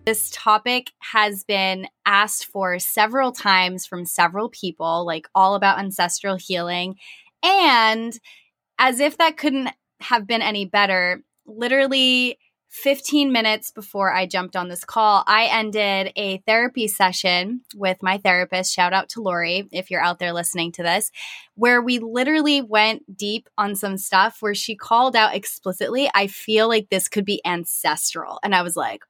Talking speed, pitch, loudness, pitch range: 160 wpm, 205 Hz, -20 LUFS, 185-230 Hz